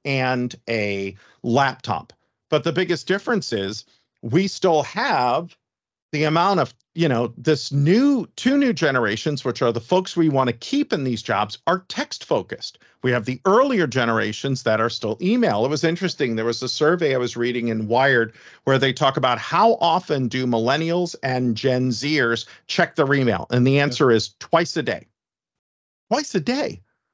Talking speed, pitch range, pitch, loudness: 175 wpm, 115-165 Hz, 130 Hz, -21 LUFS